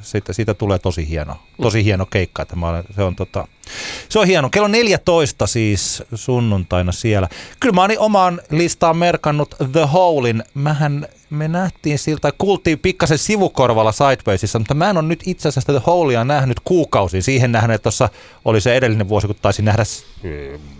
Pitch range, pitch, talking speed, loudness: 105-165 Hz, 125 Hz, 170 wpm, -17 LUFS